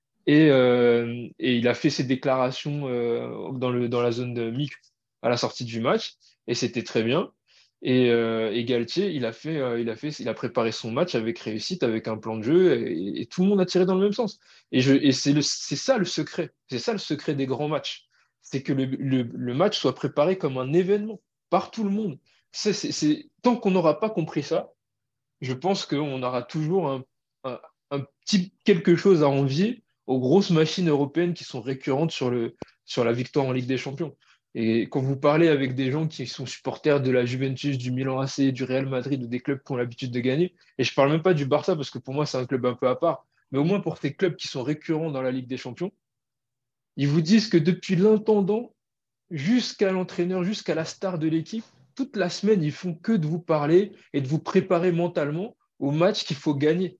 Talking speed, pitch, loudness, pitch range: 230 wpm, 145 Hz, -25 LUFS, 130-180 Hz